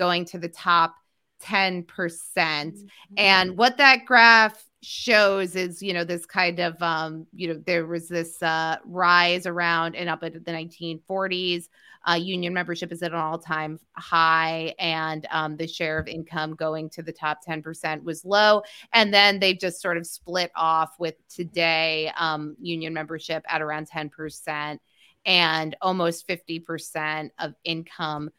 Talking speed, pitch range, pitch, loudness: 155 wpm, 160-180 Hz, 170 Hz, -23 LUFS